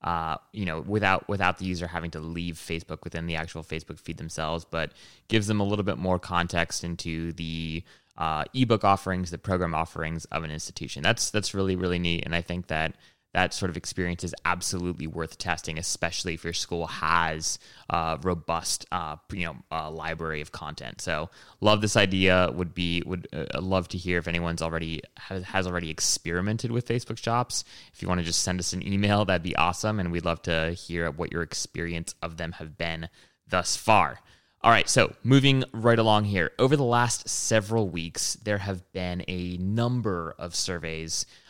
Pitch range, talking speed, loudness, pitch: 85-100 Hz, 190 wpm, -27 LUFS, 90 Hz